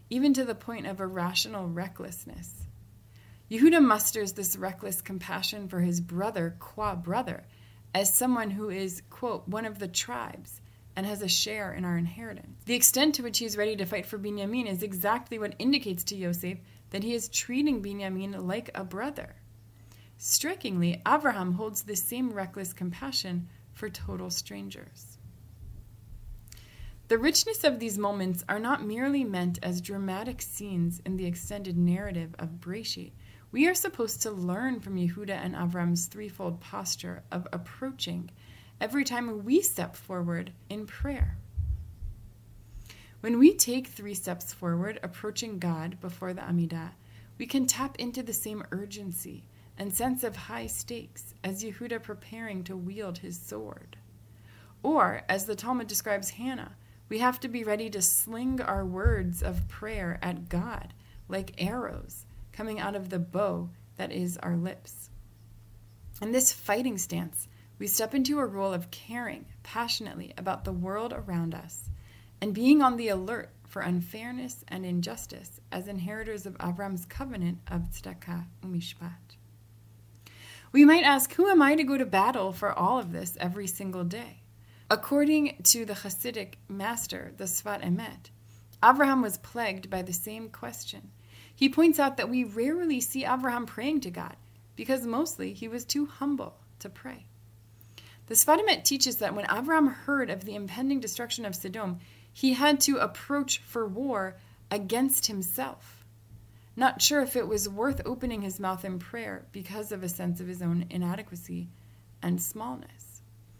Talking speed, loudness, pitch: 155 wpm, -29 LUFS, 190 Hz